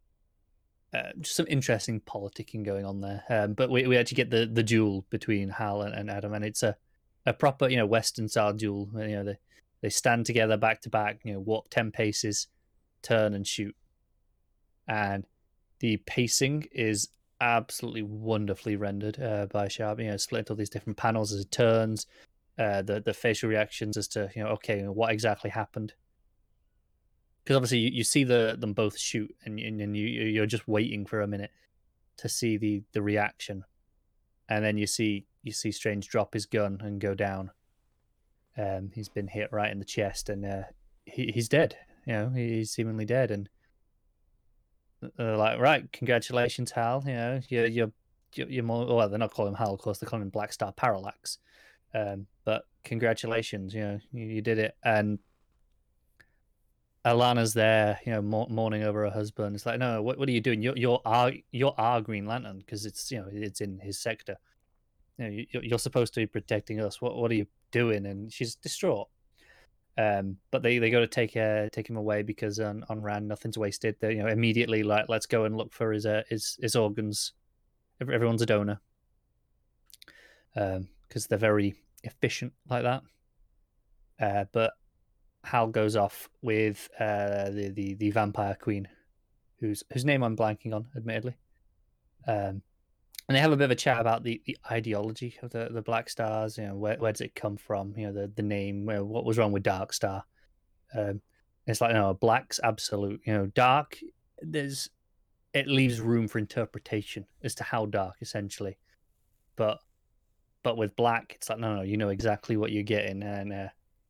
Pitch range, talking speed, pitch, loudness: 105-115 Hz, 190 wpm, 110 Hz, -30 LUFS